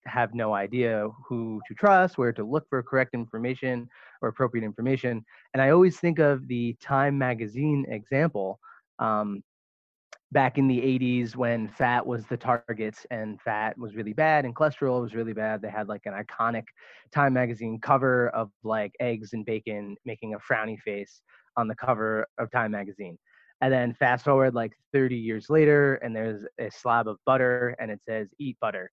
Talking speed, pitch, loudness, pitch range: 180 wpm, 120 Hz, -26 LUFS, 110-130 Hz